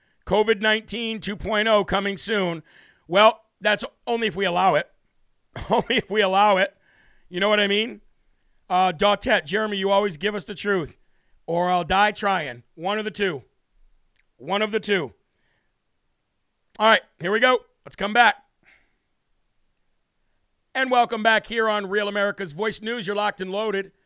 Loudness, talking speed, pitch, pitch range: -22 LUFS, 160 wpm, 205 Hz, 195-220 Hz